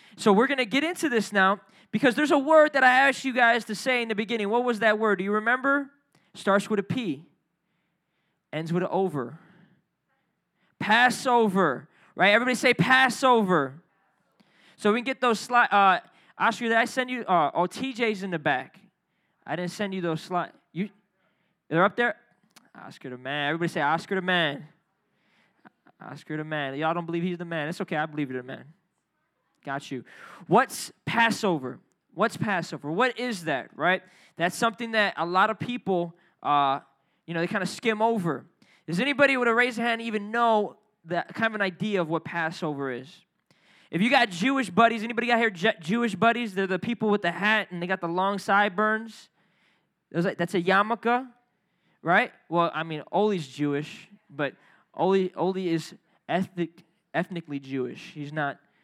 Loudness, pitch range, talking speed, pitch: -25 LUFS, 170-230 Hz, 180 wpm, 190 Hz